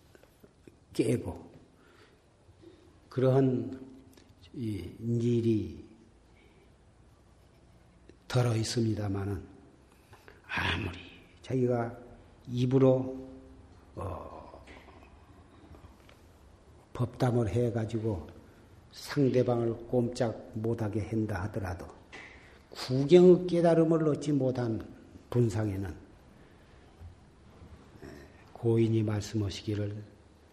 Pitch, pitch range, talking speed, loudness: 110 Hz, 90-120 Hz, 140 characters per minute, -30 LUFS